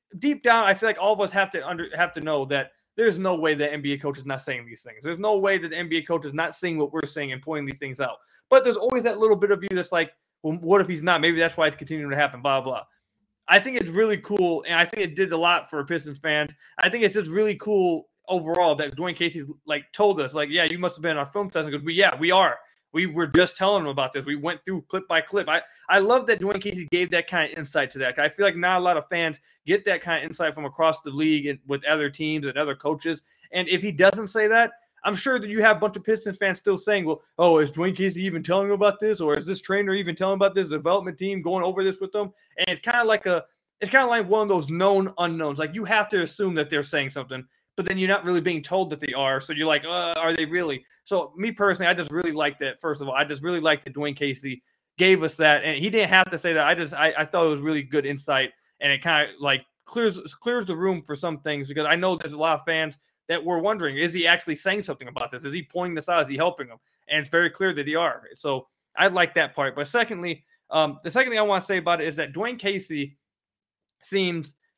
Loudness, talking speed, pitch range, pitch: -23 LUFS, 285 wpm, 150-195 Hz, 170 Hz